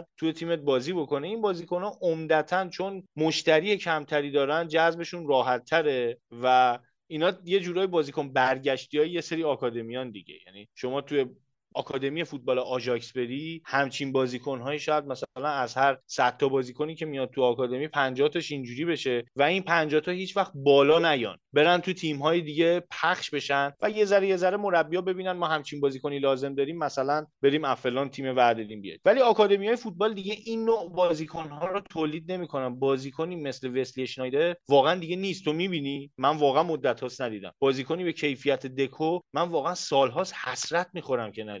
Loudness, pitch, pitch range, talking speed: -27 LUFS, 150 Hz, 135-170 Hz, 165 wpm